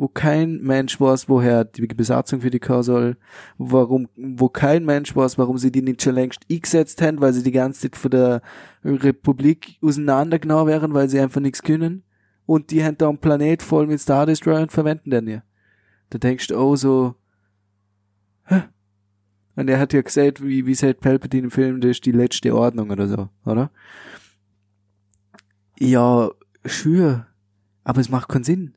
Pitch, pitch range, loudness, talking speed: 130 Hz, 115-145 Hz, -19 LUFS, 175 wpm